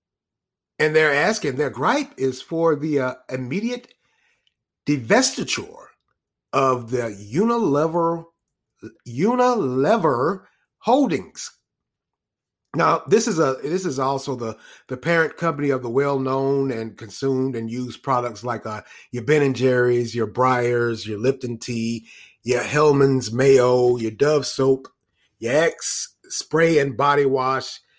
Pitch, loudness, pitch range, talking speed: 135 Hz, -21 LUFS, 125-150 Hz, 125 wpm